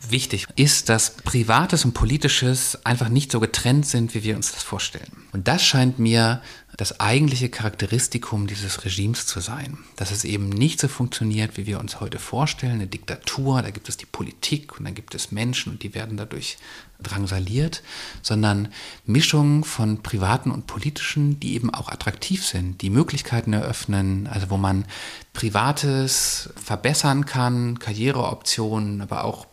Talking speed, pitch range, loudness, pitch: 160 wpm, 105-135 Hz, -22 LUFS, 115 Hz